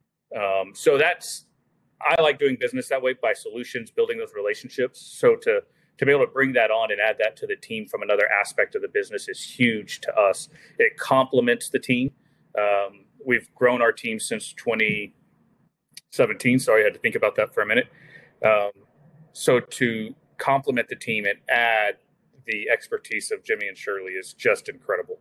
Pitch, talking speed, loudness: 225 Hz, 185 wpm, -23 LUFS